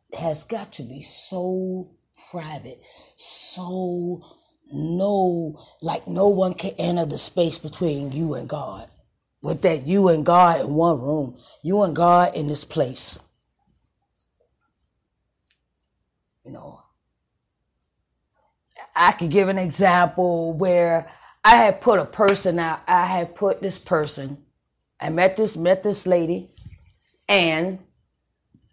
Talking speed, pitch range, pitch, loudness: 125 wpm, 150-185 Hz, 170 Hz, -21 LUFS